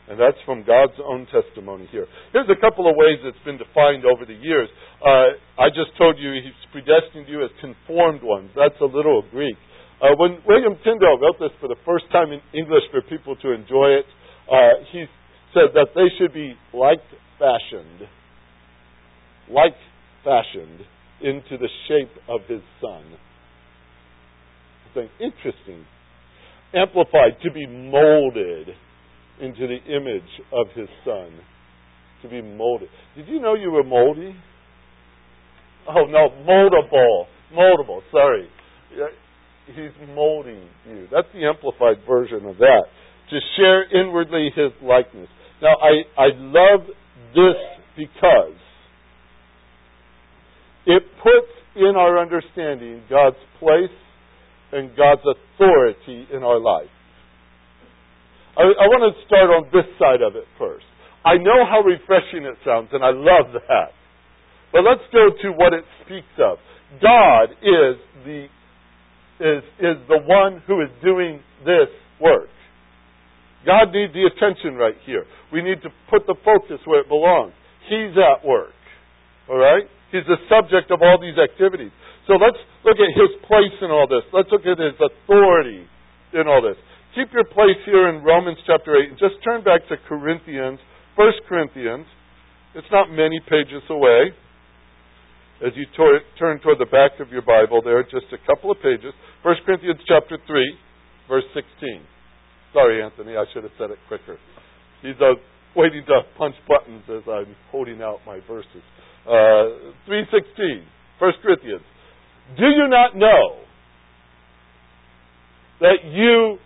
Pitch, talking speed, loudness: 150 Hz, 145 wpm, -17 LUFS